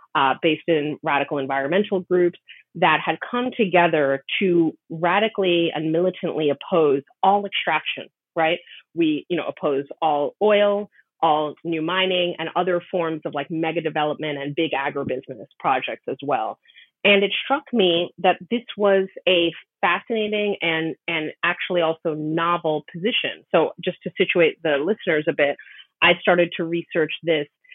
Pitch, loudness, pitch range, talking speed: 170 Hz, -22 LUFS, 155-190 Hz, 145 wpm